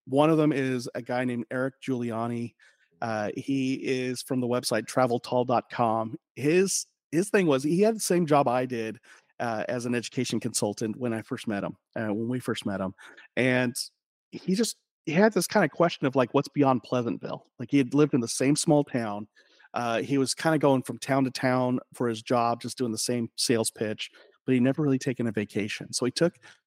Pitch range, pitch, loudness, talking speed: 120-145 Hz, 125 Hz, -27 LUFS, 215 wpm